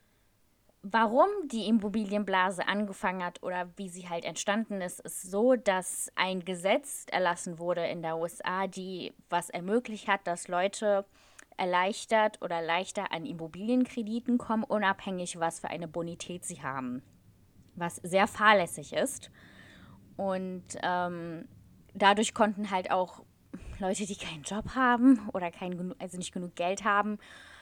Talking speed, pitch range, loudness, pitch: 135 wpm, 170-210 Hz, -30 LUFS, 185 Hz